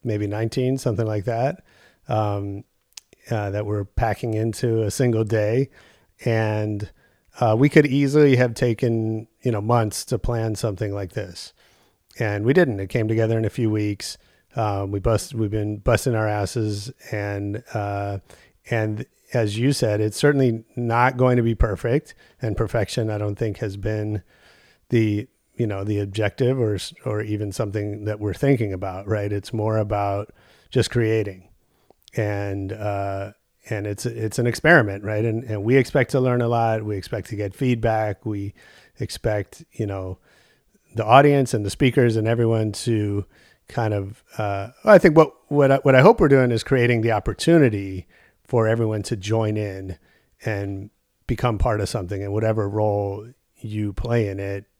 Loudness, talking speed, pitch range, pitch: -22 LUFS, 170 wpm, 105-120 Hz, 110 Hz